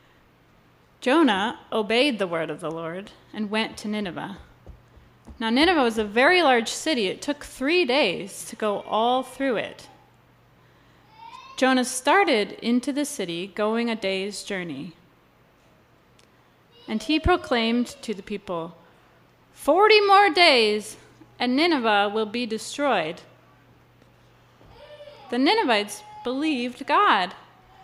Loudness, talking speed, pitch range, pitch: -22 LUFS, 115 wpm, 210-285 Hz, 245 Hz